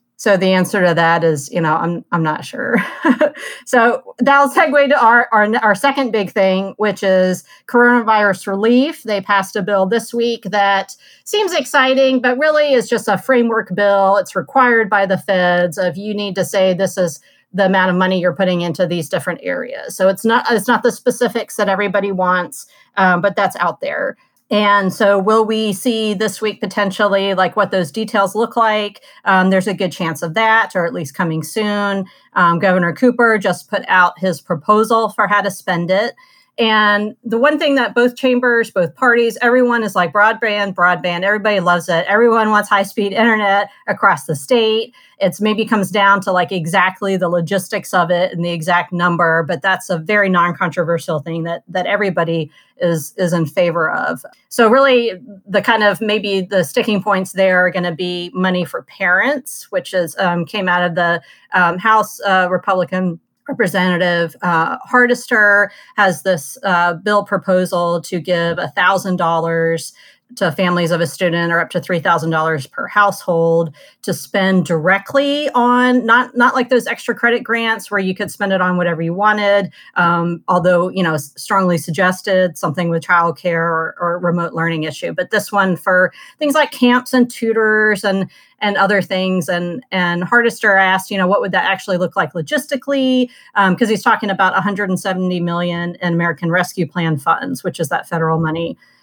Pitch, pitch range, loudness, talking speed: 195 Hz, 175-225 Hz, -15 LUFS, 185 wpm